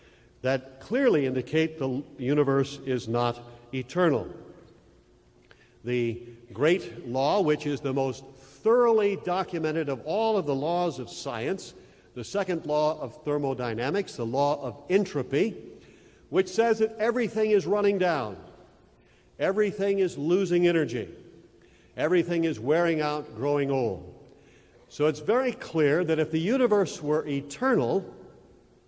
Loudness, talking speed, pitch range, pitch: -27 LUFS, 125 wpm, 130-185 Hz, 150 Hz